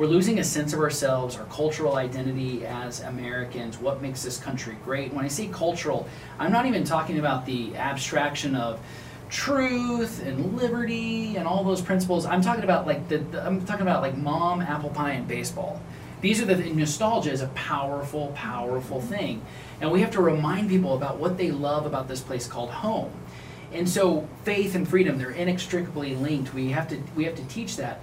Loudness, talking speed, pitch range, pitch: -27 LUFS, 190 wpm, 135-180 Hz, 150 Hz